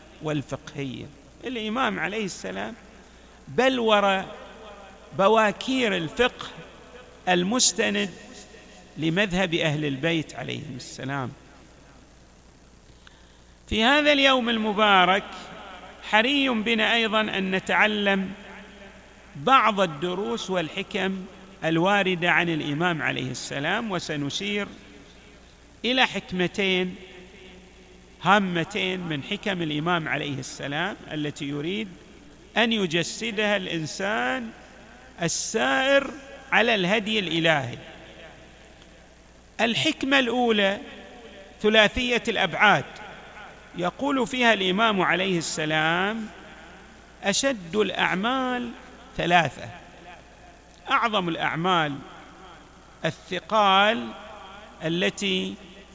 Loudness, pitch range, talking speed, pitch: -23 LUFS, 170-220 Hz, 70 wpm, 195 Hz